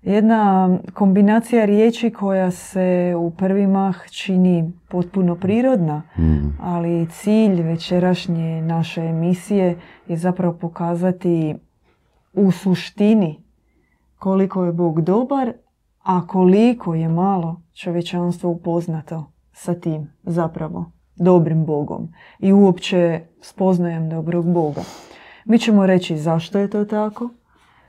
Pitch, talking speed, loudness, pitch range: 180 Hz, 105 wpm, -19 LUFS, 170-195 Hz